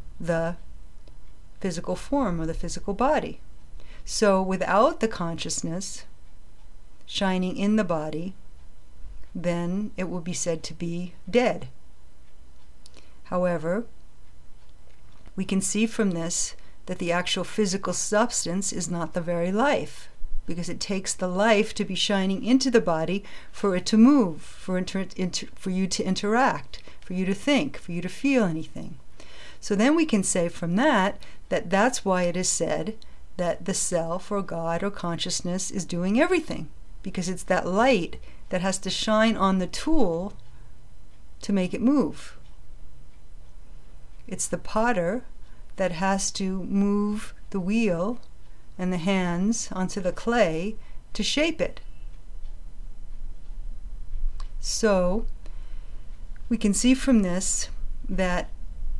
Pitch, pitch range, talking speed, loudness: 185 Hz, 165-210 Hz, 135 wpm, -25 LUFS